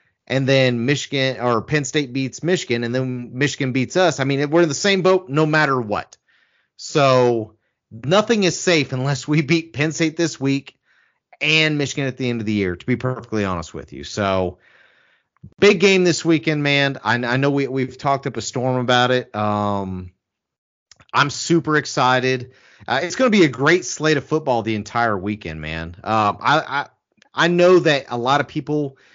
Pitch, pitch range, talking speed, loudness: 135 Hz, 120-155 Hz, 190 wpm, -19 LUFS